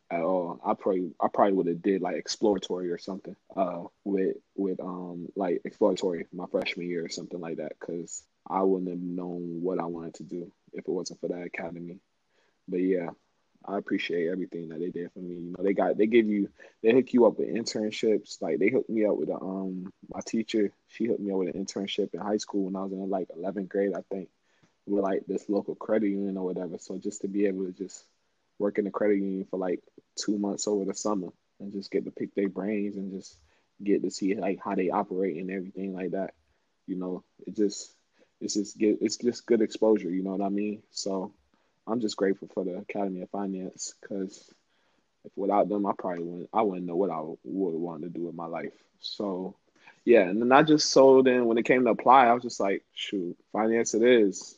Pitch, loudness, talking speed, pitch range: 95 Hz, -28 LUFS, 225 wpm, 90-105 Hz